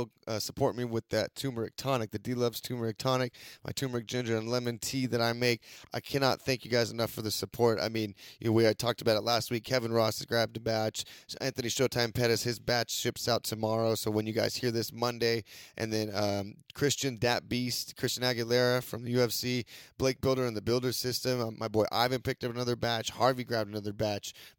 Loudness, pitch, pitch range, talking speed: -31 LUFS, 120 Hz, 110-125 Hz, 220 wpm